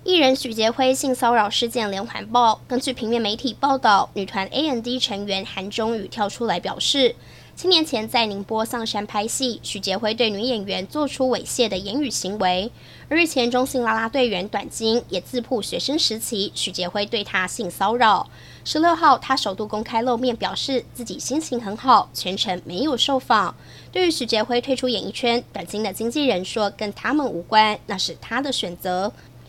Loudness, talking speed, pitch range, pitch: -21 LUFS, 285 characters per minute, 200-255 Hz, 230 Hz